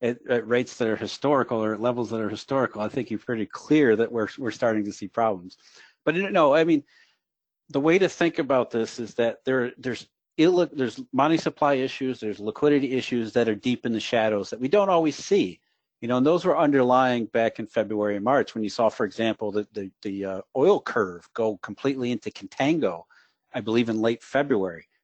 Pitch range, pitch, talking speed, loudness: 110-135 Hz, 120 Hz, 210 wpm, -24 LUFS